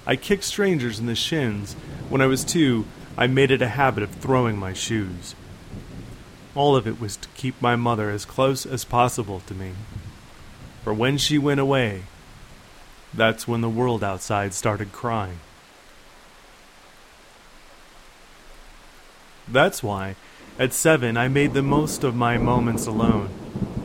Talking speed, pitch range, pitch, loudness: 145 wpm, 105-130 Hz, 115 Hz, -22 LUFS